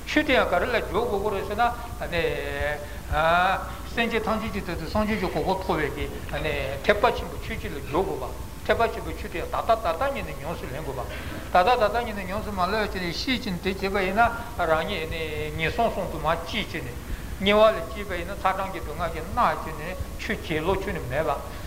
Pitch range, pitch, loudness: 190-235 Hz, 215 Hz, -26 LUFS